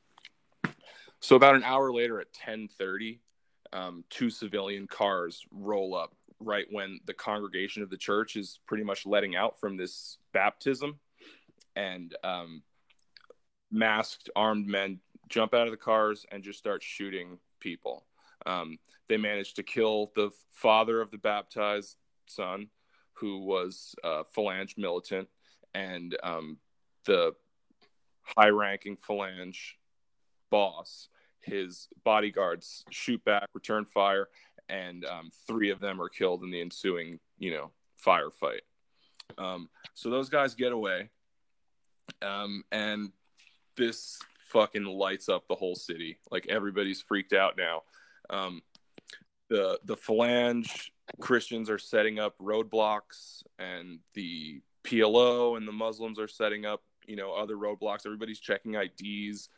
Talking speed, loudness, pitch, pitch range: 130 wpm, -31 LUFS, 105 Hz, 95-110 Hz